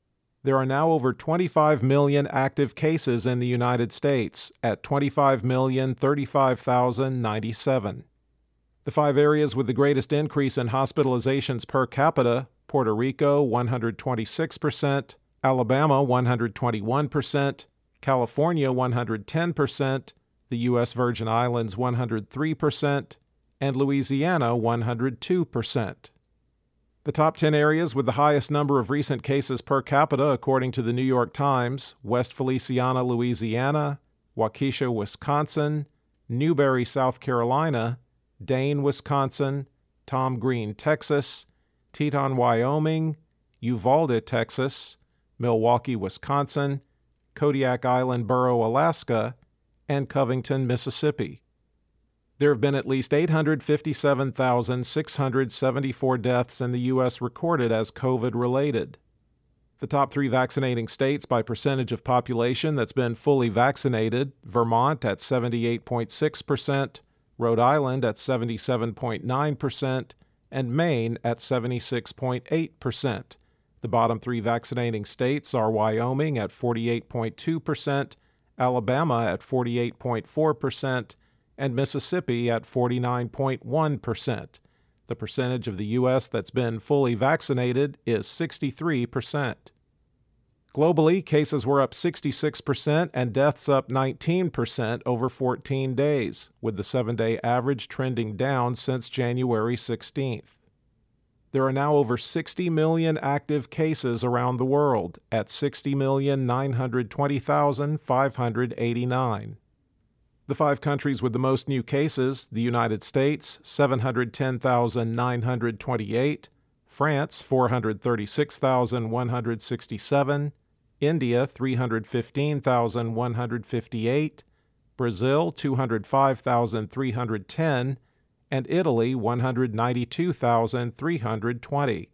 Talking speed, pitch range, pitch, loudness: 95 wpm, 120-140 Hz, 130 Hz, -25 LUFS